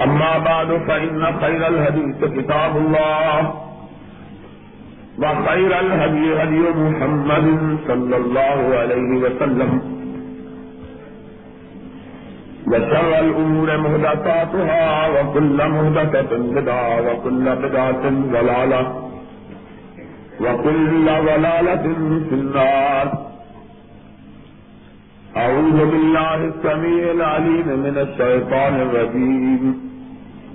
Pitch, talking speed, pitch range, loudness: 155 Hz, 70 wpm, 130-160 Hz, -17 LUFS